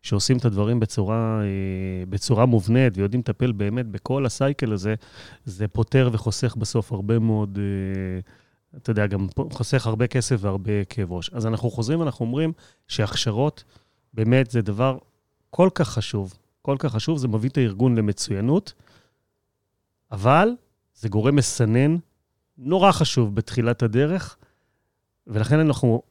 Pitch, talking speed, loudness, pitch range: 115 Hz, 130 wpm, -23 LUFS, 105-130 Hz